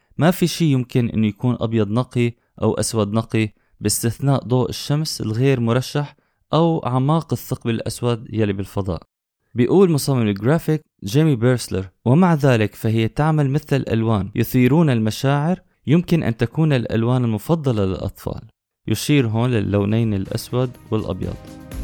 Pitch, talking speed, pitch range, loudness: 120 Hz, 125 wpm, 110-140 Hz, -20 LUFS